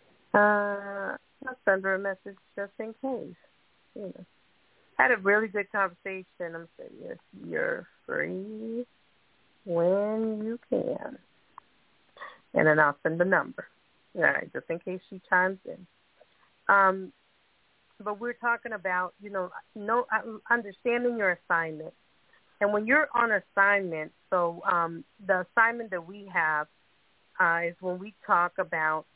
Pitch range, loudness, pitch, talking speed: 180-220 Hz, -28 LUFS, 195 Hz, 135 wpm